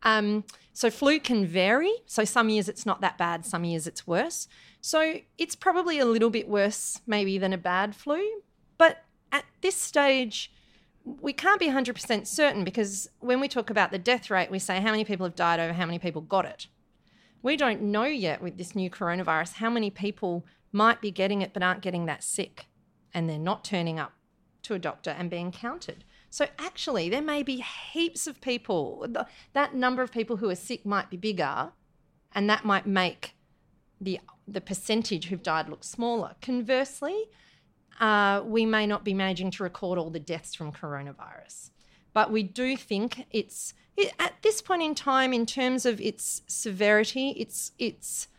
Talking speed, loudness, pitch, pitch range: 185 wpm, -28 LUFS, 210 Hz, 185-255 Hz